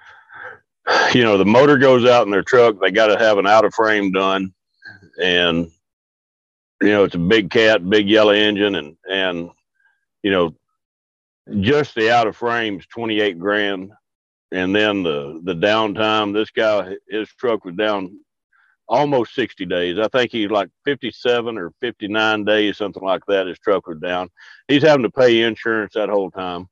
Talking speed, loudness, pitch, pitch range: 175 wpm, -17 LUFS, 105 Hz, 95-115 Hz